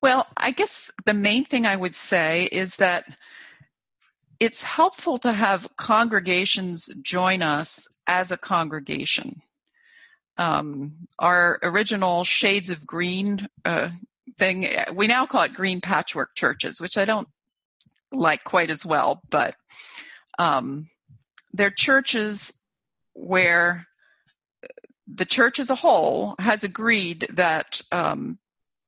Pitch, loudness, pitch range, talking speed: 195 Hz, -22 LUFS, 175-235 Hz, 120 wpm